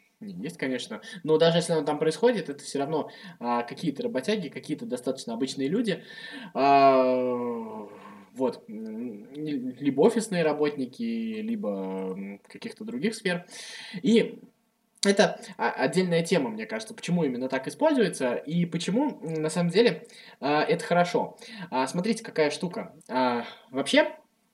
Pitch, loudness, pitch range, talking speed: 180 Hz, -27 LUFS, 140-225 Hz, 125 wpm